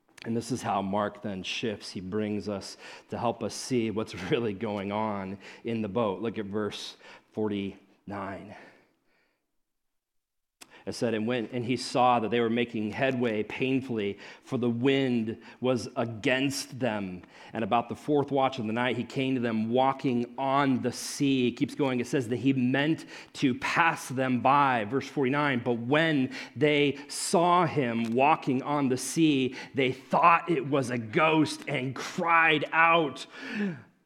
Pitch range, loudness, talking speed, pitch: 110-140 Hz, -28 LUFS, 160 wpm, 125 Hz